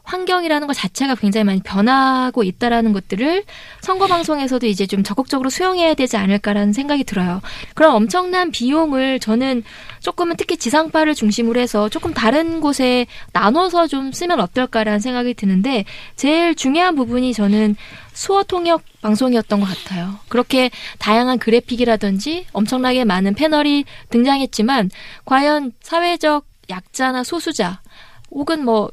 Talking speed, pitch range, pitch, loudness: 350 characters per minute, 215-310 Hz, 255 Hz, -17 LUFS